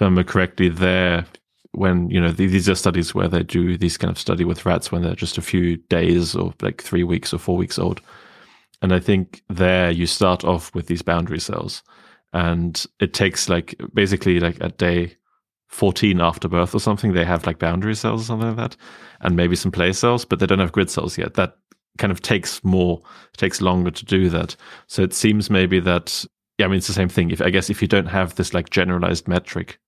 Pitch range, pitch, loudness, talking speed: 85-95 Hz, 90 Hz, -20 LUFS, 220 wpm